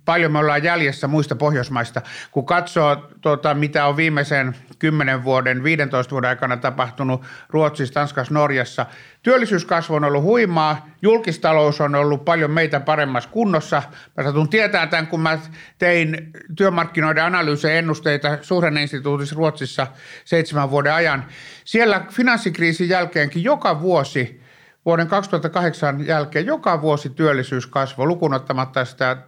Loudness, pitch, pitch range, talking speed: -19 LUFS, 150 Hz, 140-170 Hz, 125 wpm